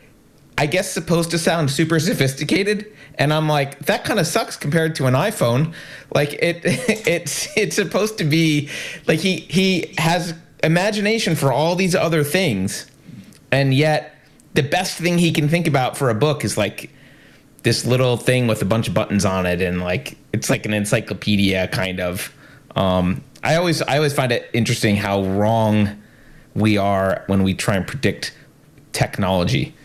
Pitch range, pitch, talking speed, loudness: 110-165 Hz, 145 Hz, 170 wpm, -19 LUFS